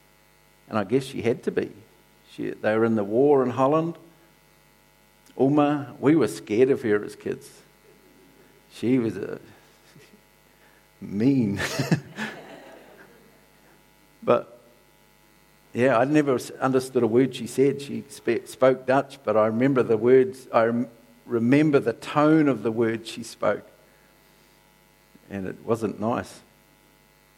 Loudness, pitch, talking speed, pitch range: -24 LUFS, 130 Hz, 125 wpm, 115-140 Hz